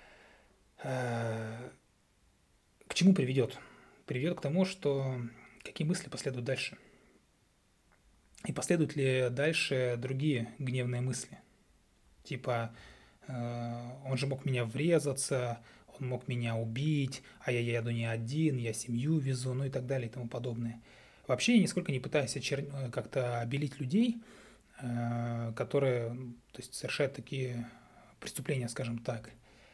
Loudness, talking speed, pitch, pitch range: -34 LUFS, 120 wpm, 130 Hz, 120-140 Hz